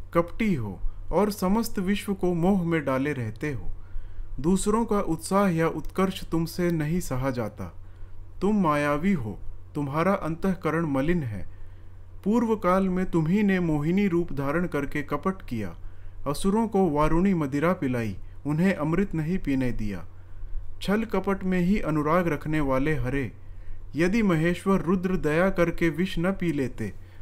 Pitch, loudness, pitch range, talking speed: 160 Hz, -26 LUFS, 110-185 Hz, 145 wpm